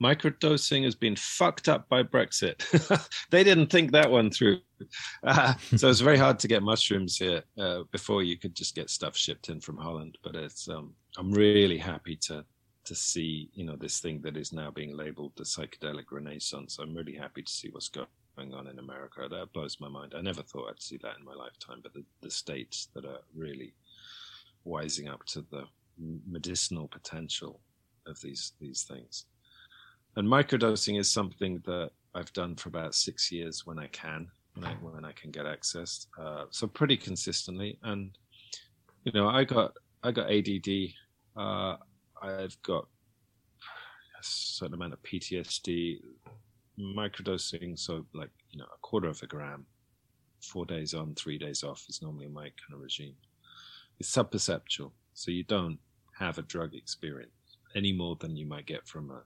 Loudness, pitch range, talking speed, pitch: -30 LUFS, 75-105 Hz, 175 wpm, 90 Hz